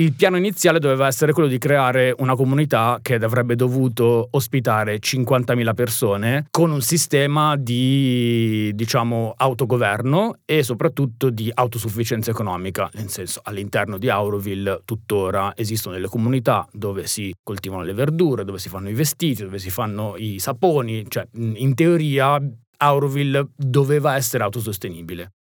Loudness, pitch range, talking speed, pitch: -20 LUFS, 105-140 Hz, 135 wpm, 120 Hz